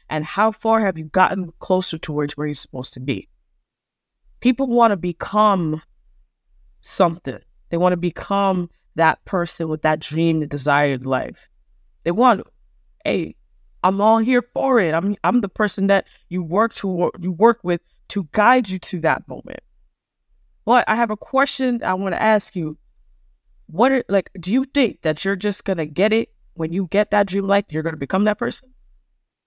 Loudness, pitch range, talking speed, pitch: -20 LUFS, 155-215 Hz, 180 wpm, 185 Hz